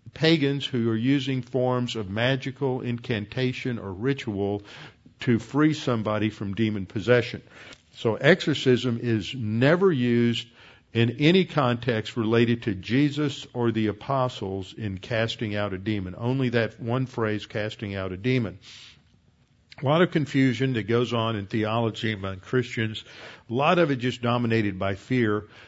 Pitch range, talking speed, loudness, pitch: 110-130 Hz, 145 wpm, -25 LUFS, 120 Hz